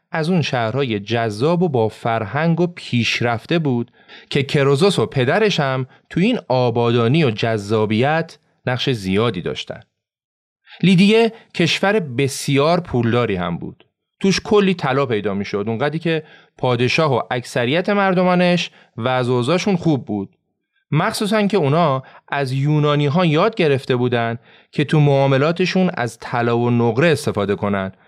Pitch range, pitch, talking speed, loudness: 120-175 Hz, 140 Hz, 135 wpm, -18 LUFS